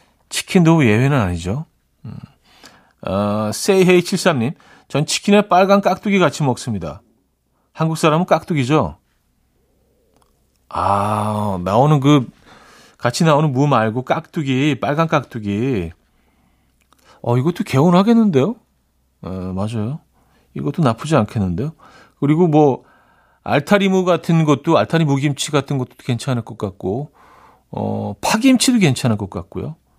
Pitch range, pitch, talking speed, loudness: 105-165 Hz, 140 Hz, 260 characters per minute, -17 LUFS